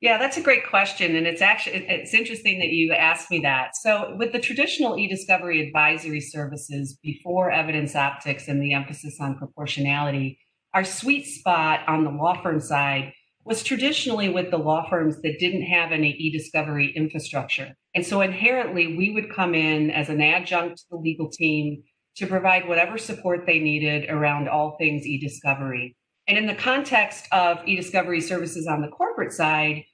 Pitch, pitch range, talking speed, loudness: 165 Hz, 150-190 Hz, 170 wpm, -22 LUFS